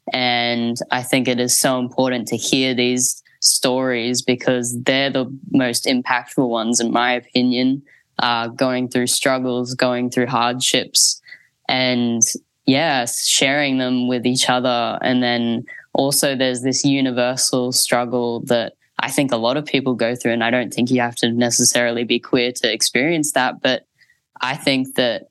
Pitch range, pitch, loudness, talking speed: 120-130 Hz, 125 Hz, -18 LUFS, 160 wpm